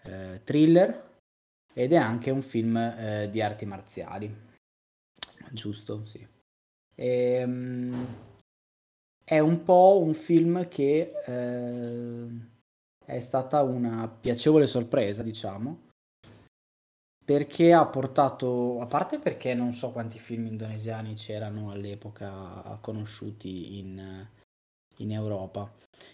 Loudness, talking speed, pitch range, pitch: -27 LUFS, 100 wpm, 100-125 Hz, 115 Hz